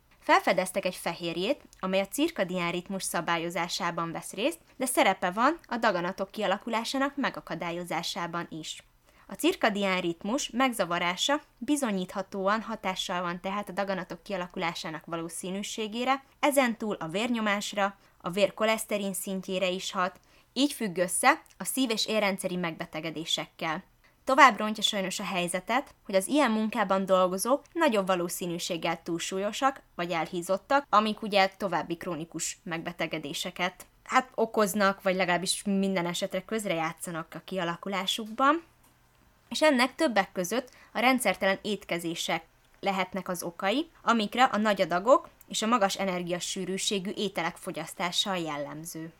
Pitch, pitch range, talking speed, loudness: 195 Hz, 175-220 Hz, 120 wpm, -29 LUFS